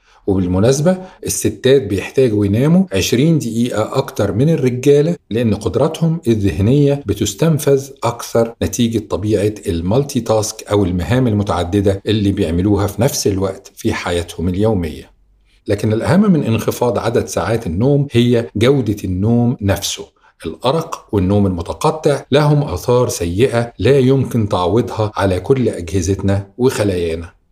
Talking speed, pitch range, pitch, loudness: 115 wpm, 100-135 Hz, 110 Hz, -16 LUFS